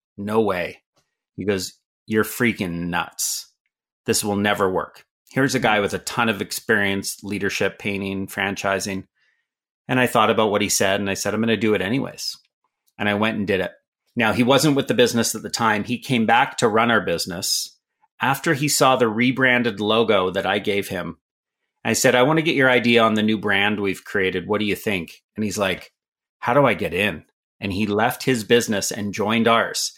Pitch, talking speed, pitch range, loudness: 105 Hz, 210 wpm, 100-120 Hz, -20 LUFS